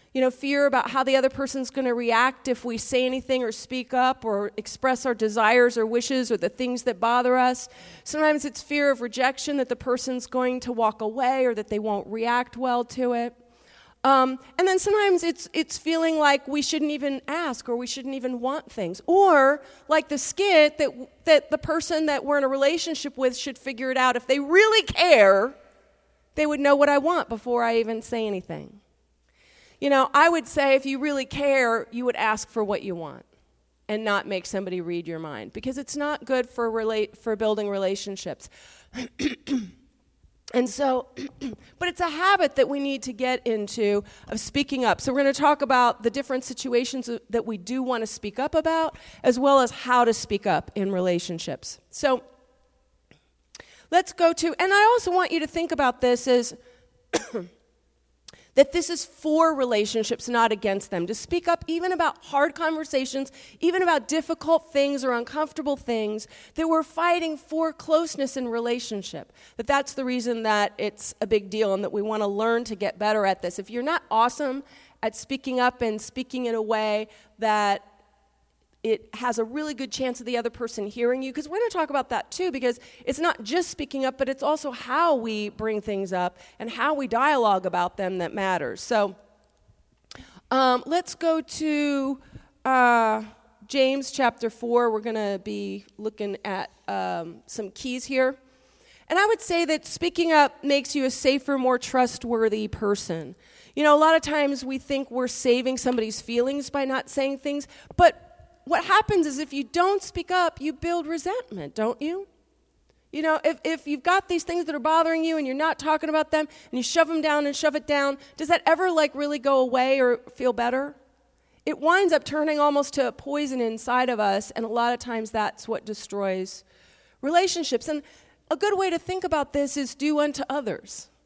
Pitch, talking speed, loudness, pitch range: 260 Hz, 195 wpm, -24 LUFS, 230-300 Hz